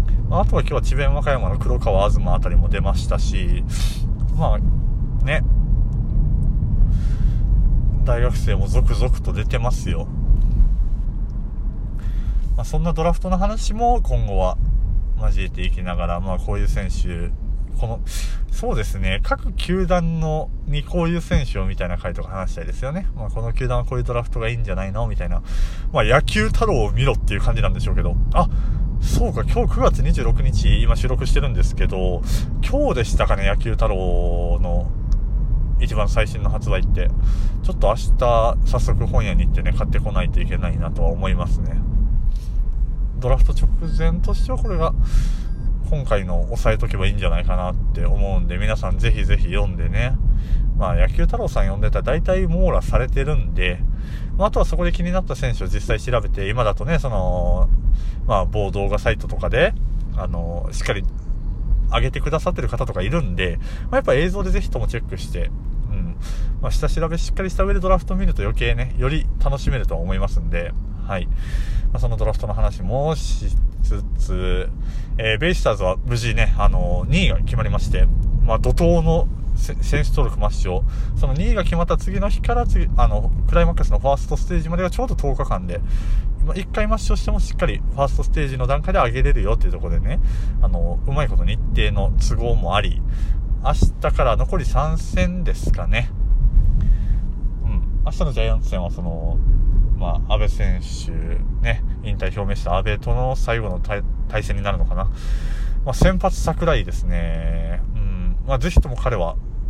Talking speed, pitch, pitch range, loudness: 345 characters per minute, 105 Hz, 95-125 Hz, -22 LUFS